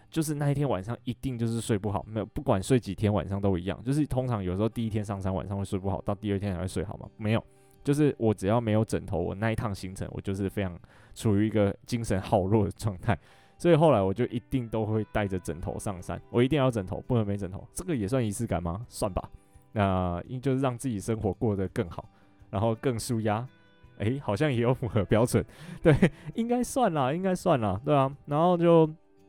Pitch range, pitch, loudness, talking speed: 100-130 Hz, 110 Hz, -28 LUFS, 340 characters per minute